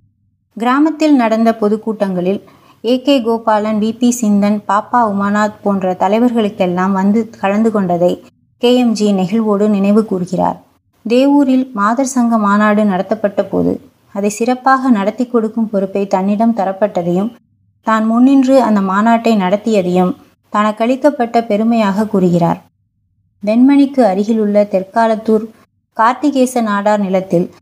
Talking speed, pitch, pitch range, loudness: 105 wpm, 215 Hz, 195-230 Hz, -13 LUFS